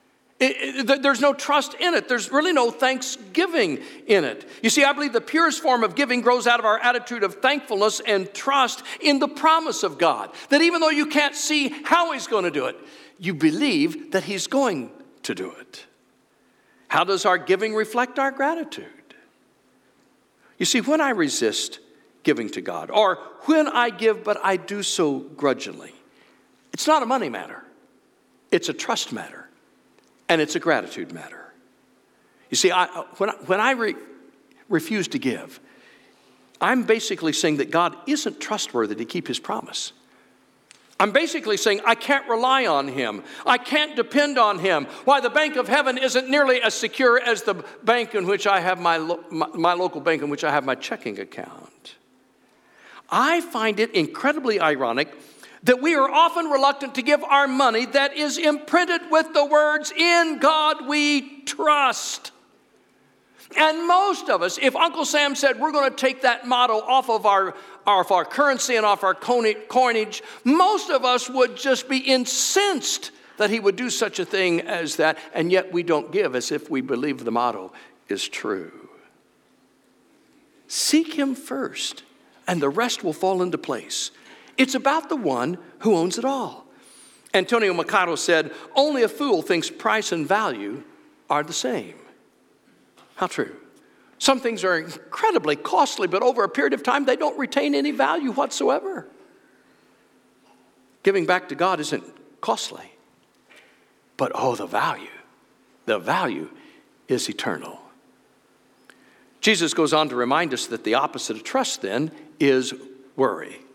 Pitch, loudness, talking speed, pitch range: 260 Hz, -21 LUFS, 165 wpm, 200-295 Hz